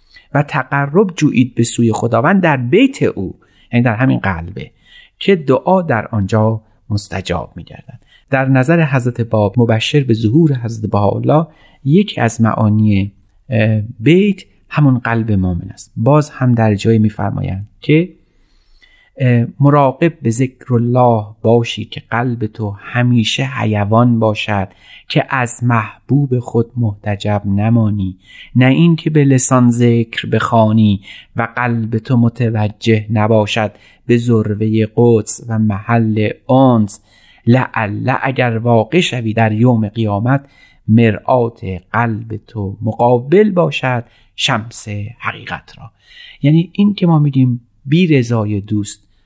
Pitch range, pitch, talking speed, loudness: 105-130 Hz, 115 Hz, 120 wpm, -14 LUFS